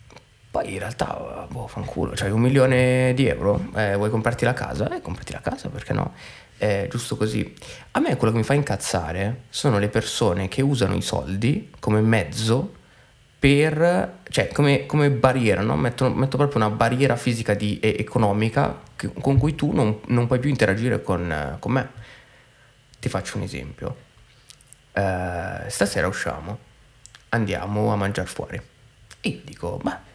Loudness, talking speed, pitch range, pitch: -23 LUFS, 165 wpm, 105-130 Hz, 115 Hz